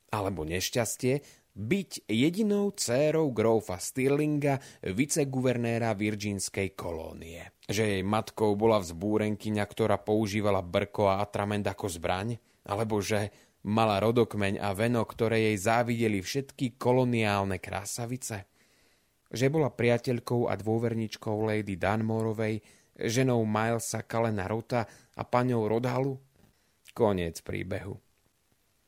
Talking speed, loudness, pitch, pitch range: 105 wpm, -29 LUFS, 110 Hz, 100-120 Hz